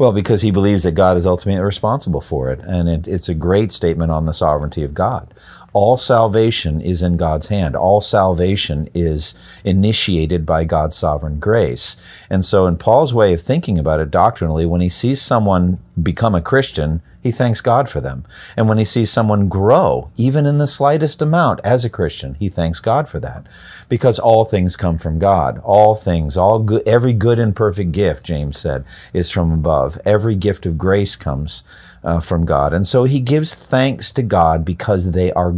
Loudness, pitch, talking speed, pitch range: -15 LUFS, 95 Hz, 195 wpm, 85-110 Hz